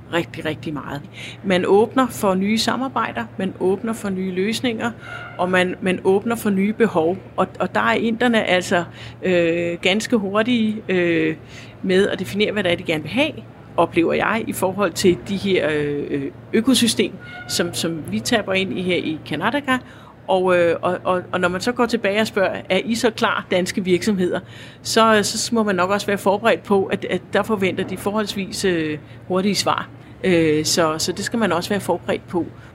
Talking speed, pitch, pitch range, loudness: 185 wpm, 185 Hz, 170-215 Hz, -20 LUFS